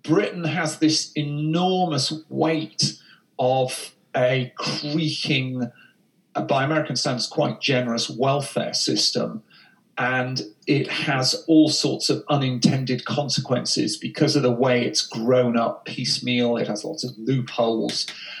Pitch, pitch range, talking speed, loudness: 135 Hz, 125-155 Hz, 115 wpm, -22 LUFS